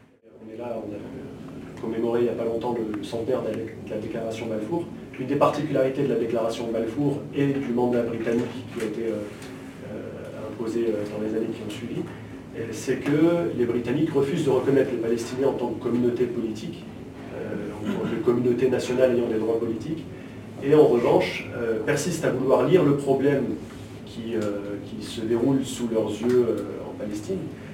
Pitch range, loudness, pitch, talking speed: 115-130 Hz, -25 LUFS, 120 Hz, 165 wpm